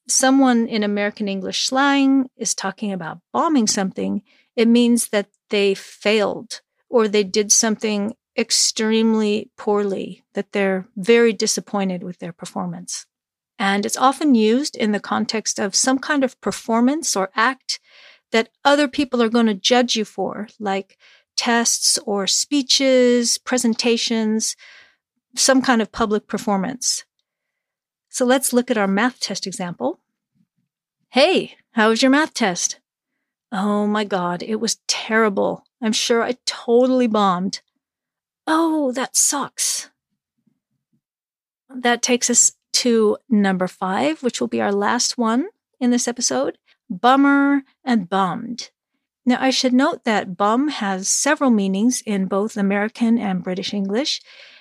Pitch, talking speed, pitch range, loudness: 230 Hz, 135 wpm, 205-255 Hz, -19 LUFS